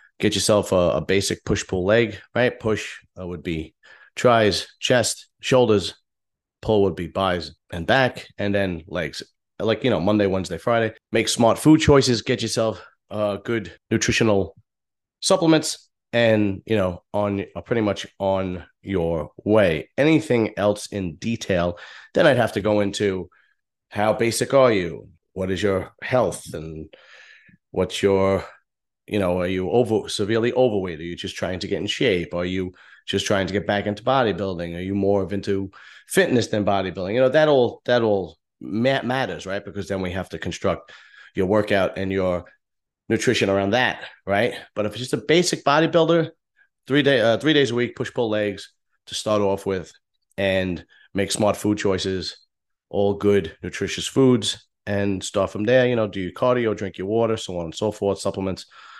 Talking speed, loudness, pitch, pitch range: 175 wpm, -22 LUFS, 100 Hz, 95-115 Hz